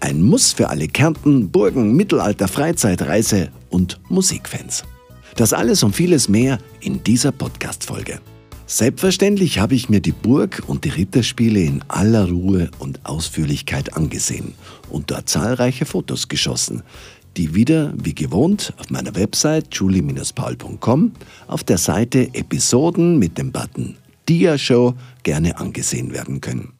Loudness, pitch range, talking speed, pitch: -18 LUFS, 90-145 Hz, 135 wpm, 115 Hz